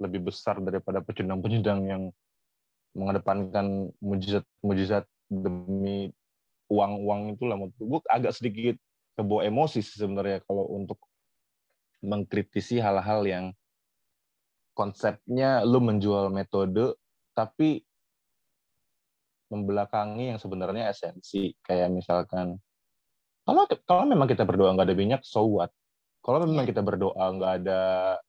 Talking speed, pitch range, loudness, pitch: 105 wpm, 95-110 Hz, -28 LUFS, 100 Hz